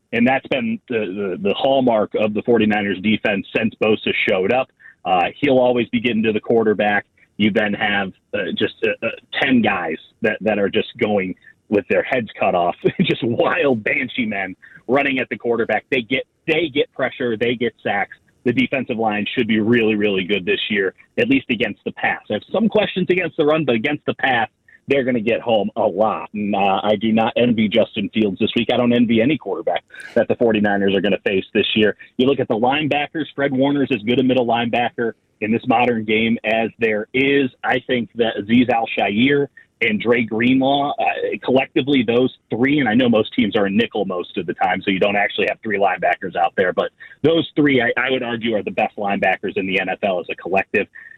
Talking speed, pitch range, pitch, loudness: 215 wpm, 110-150 Hz, 125 Hz, -19 LUFS